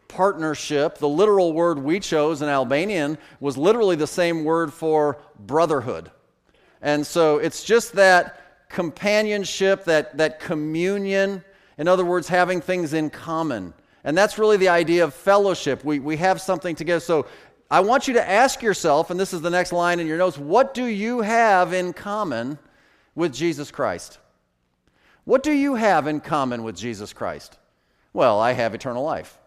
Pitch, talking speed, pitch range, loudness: 175 Hz, 165 wpm, 150-195 Hz, -21 LUFS